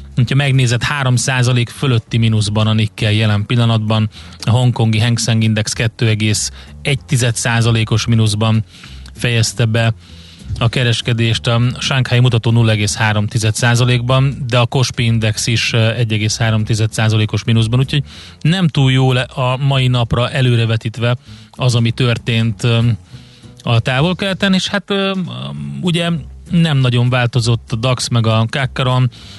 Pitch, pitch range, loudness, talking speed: 120 Hz, 110-130 Hz, -15 LUFS, 110 wpm